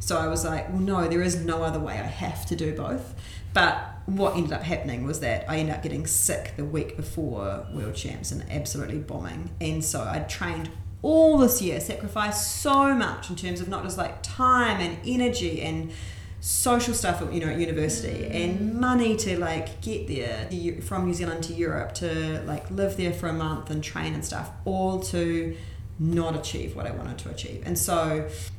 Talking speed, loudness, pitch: 200 wpm, -27 LUFS, 100 Hz